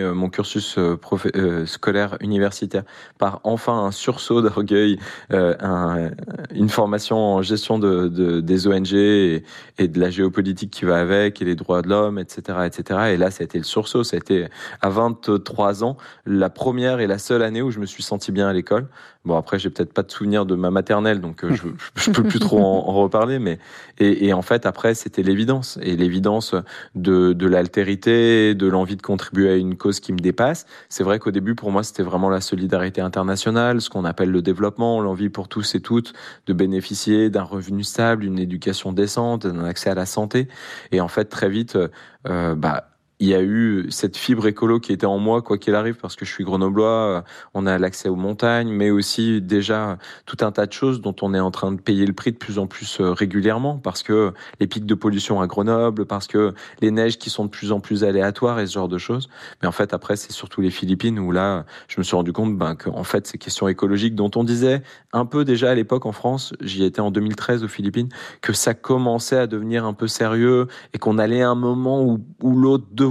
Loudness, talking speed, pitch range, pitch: -20 LUFS, 220 wpm, 95-115 Hz, 100 Hz